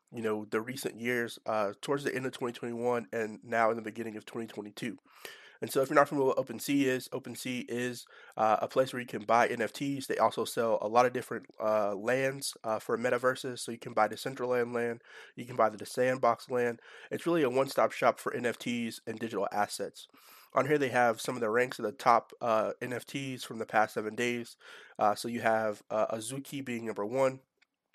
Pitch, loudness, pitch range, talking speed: 120 Hz, -32 LUFS, 115-130 Hz, 215 wpm